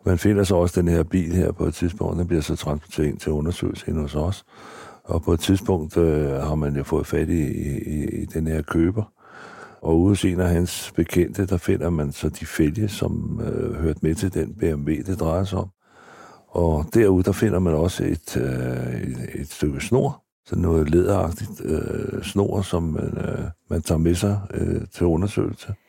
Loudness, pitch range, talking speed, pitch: -23 LUFS, 80-95 Hz, 200 wpm, 85 Hz